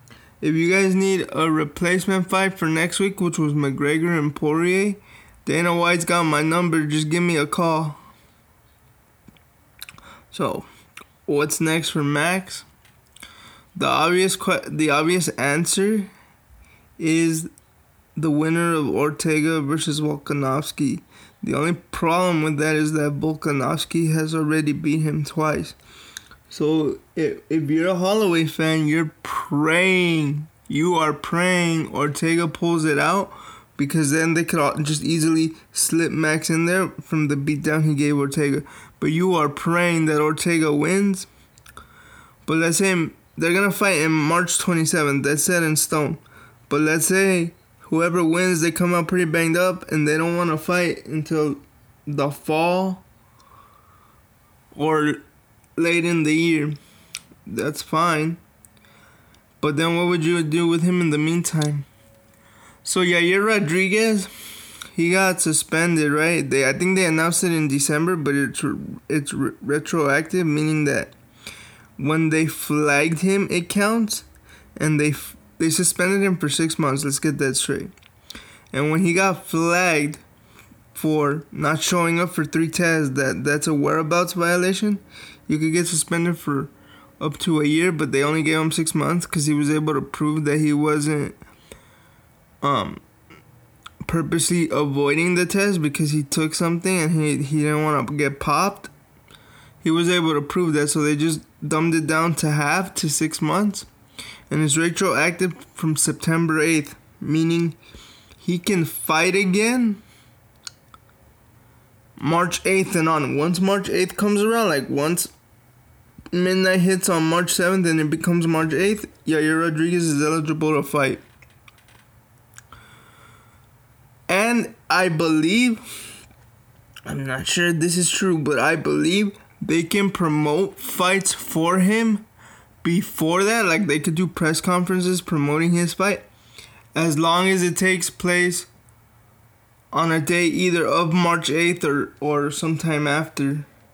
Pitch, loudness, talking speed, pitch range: 160 Hz, -20 LUFS, 145 wpm, 150-175 Hz